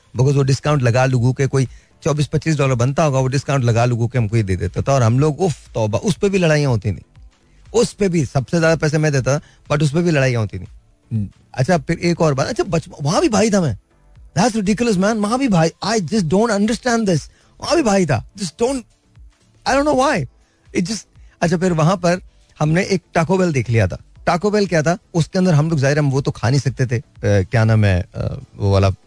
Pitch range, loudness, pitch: 125-185 Hz, -18 LUFS, 150 Hz